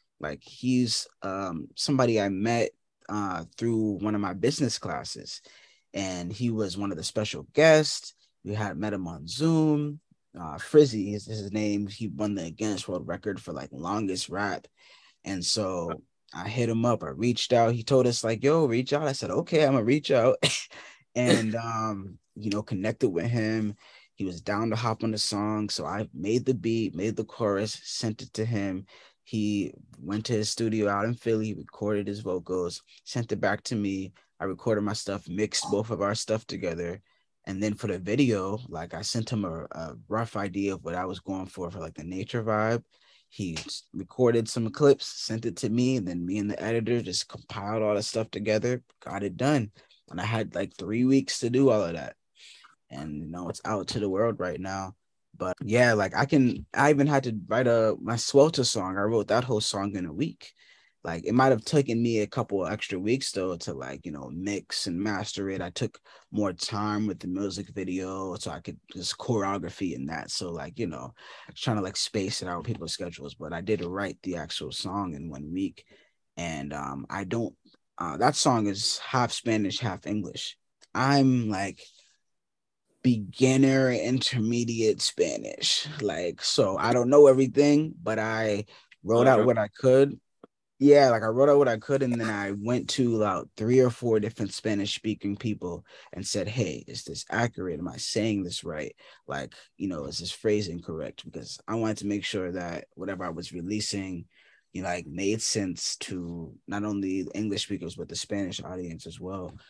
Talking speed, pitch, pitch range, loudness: 200 wpm, 110 Hz, 100-120 Hz, -28 LUFS